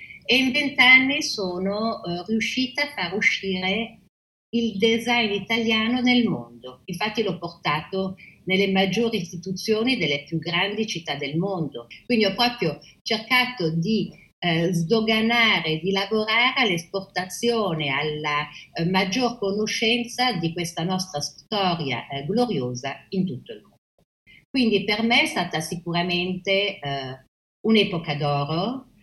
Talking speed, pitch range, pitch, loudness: 120 wpm, 170-225 Hz, 195 Hz, -23 LUFS